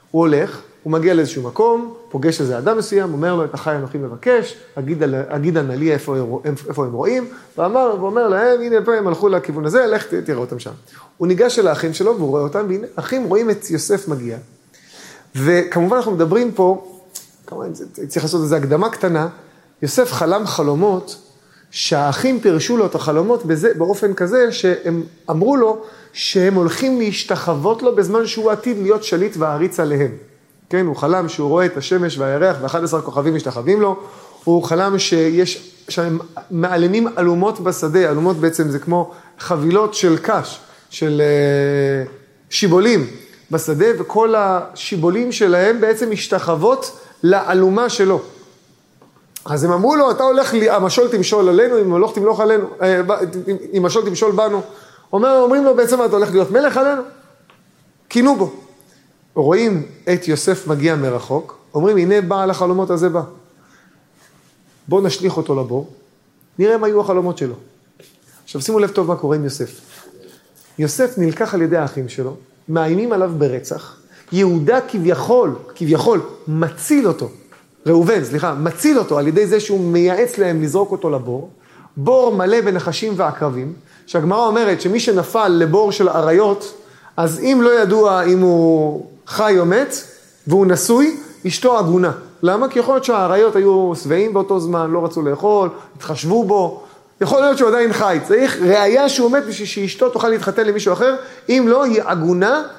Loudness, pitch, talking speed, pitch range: -16 LUFS, 185 Hz, 155 wpm, 160-220 Hz